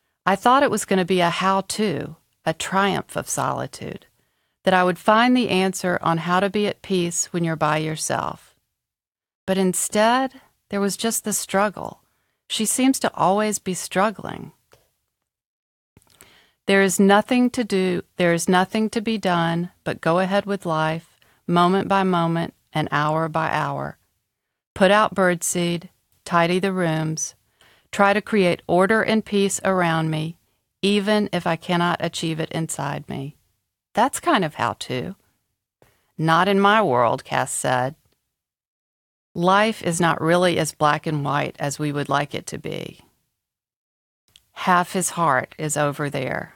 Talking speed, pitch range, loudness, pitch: 155 wpm, 160-200 Hz, -21 LUFS, 180 Hz